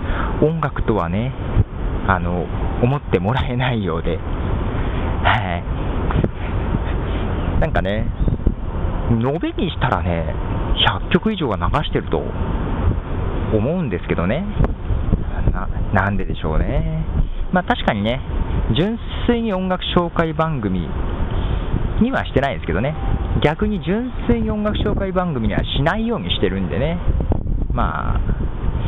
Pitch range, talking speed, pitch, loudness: 85-125 Hz, 225 characters per minute, 100 Hz, -21 LUFS